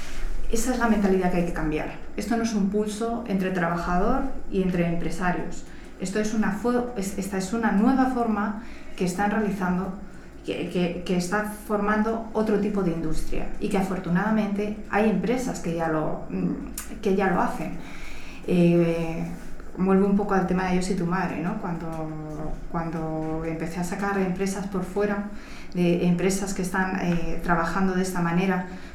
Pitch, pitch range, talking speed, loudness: 190 Hz, 175-210 Hz, 165 wpm, -26 LUFS